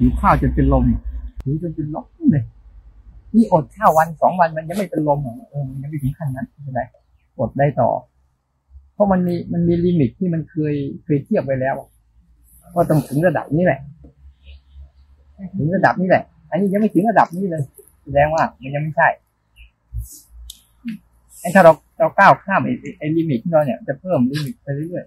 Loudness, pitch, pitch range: -18 LUFS, 145 Hz, 110-165 Hz